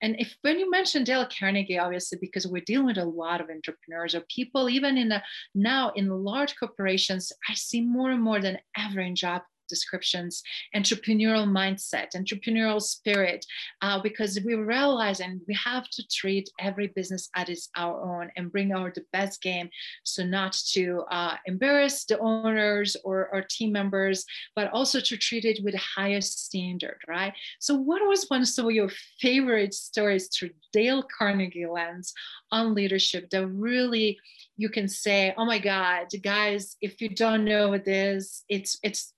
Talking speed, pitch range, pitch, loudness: 170 wpm, 185-225 Hz, 200 Hz, -27 LUFS